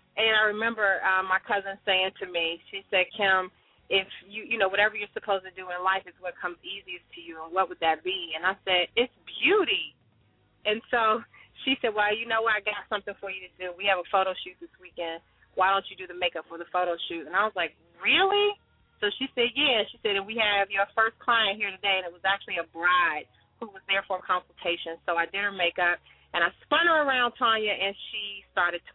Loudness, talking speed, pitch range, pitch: -26 LUFS, 245 wpm, 180-220 Hz, 195 Hz